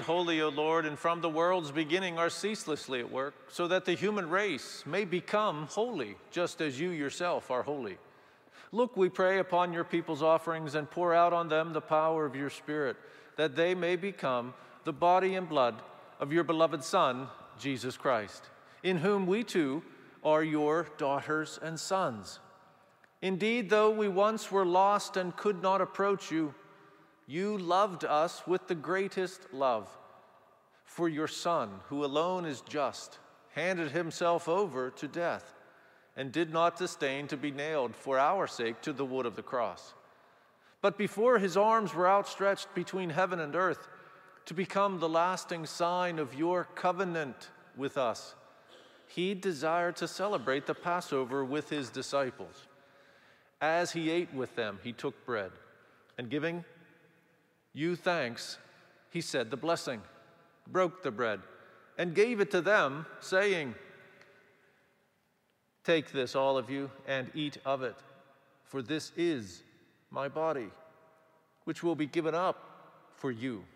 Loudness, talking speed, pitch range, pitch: -32 LUFS, 150 wpm, 150-185 Hz, 170 Hz